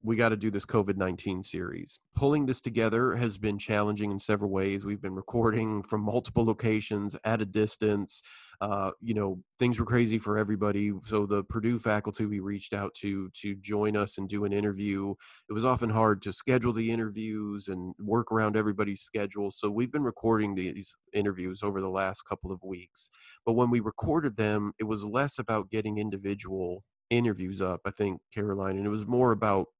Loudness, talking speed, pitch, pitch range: -30 LUFS, 190 wpm, 105 Hz, 100-110 Hz